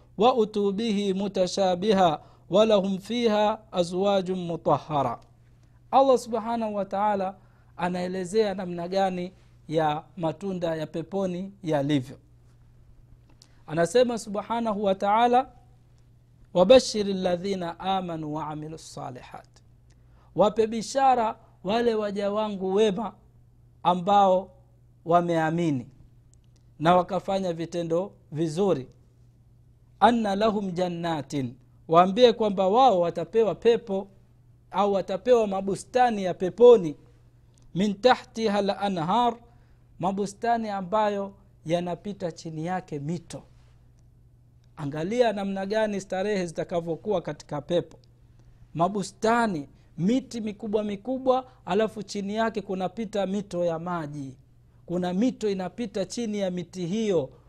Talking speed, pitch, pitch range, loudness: 90 wpm, 180 Hz, 140-205 Hz, -25 LUFS